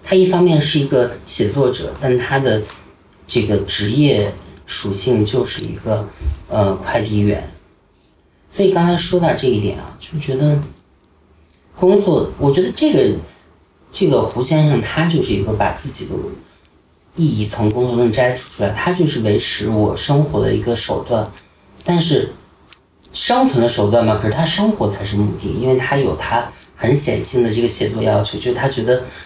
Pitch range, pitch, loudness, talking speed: 100-145 Hz, 120 Hz, -16 LUFS, 250 characters per minute